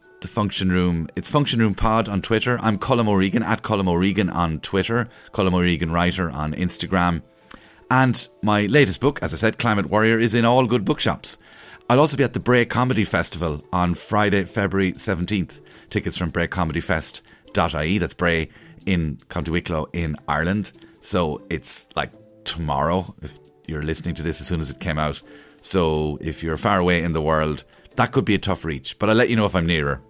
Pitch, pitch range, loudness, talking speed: 90 Hz, 80-110 Hz, -21 LUFS, 190 wpm